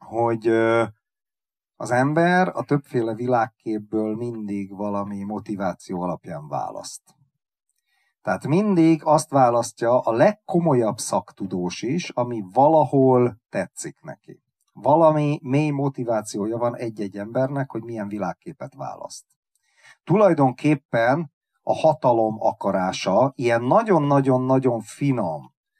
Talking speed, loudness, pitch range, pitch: 95 wpm, -22 LUFS, 115-150 Hz, 125 Hz